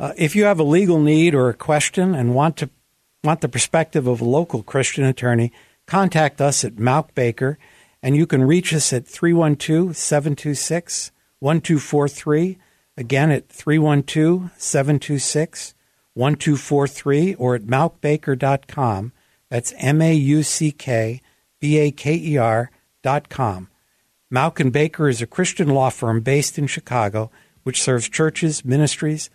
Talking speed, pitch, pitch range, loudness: 130 wpm, 145 Hz, 130-155 Hz, -19 LUFS